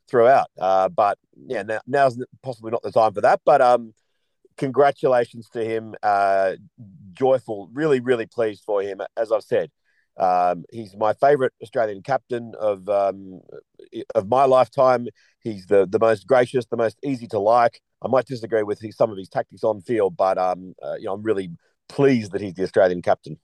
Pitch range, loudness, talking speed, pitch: 100-130 Hz, -21 LUFS, 180 wpm, 115 Hz